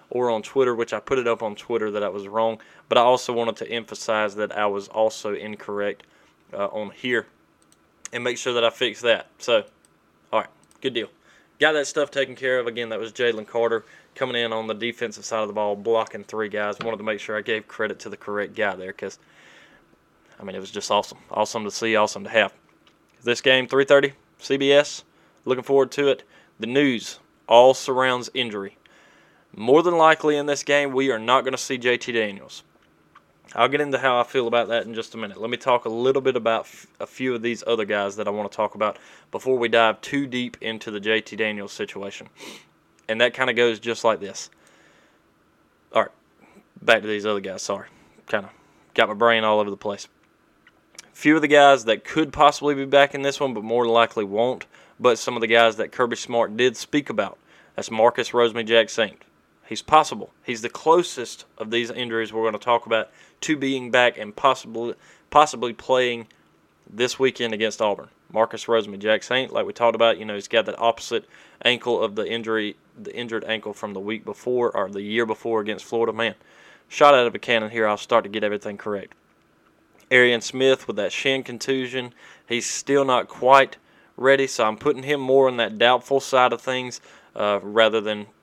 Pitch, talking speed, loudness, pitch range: 115 Hz, 210 wpm, -22 LUFS, 110-130 Hz